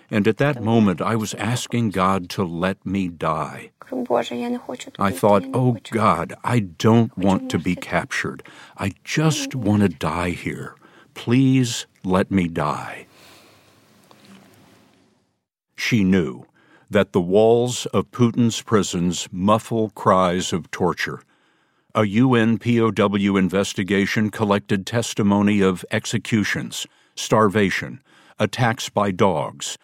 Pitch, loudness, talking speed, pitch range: 110 Hz, -21 LUFS, 110 wpm, 95-120 Hz